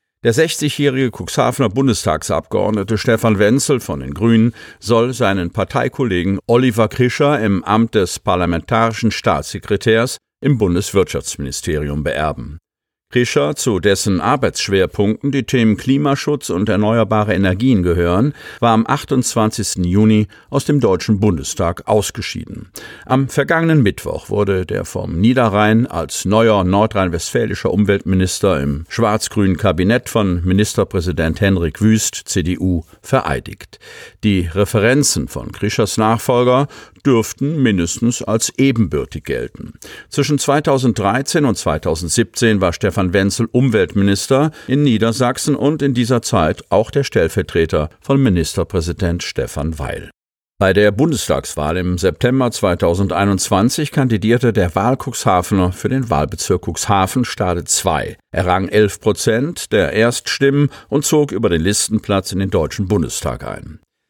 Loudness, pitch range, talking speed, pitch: -16 LUFS, 95-125 Hz, 115 wpm, 110 Hz